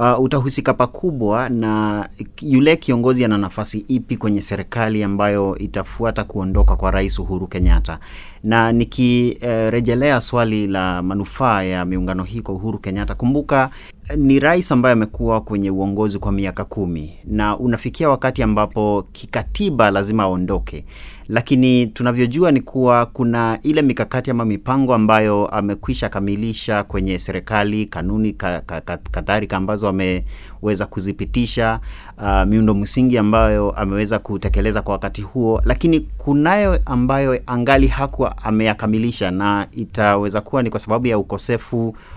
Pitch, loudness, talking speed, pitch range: 110 Hz, -18 LUFS, 130 wpm, 100-125 Hz